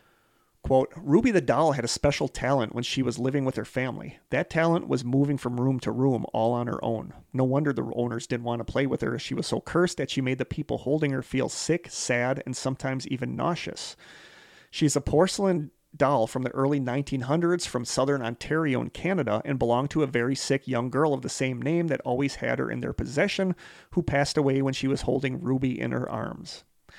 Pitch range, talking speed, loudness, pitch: 125-145 Hz, 220 wpm, -27 LUFS, 135 Hz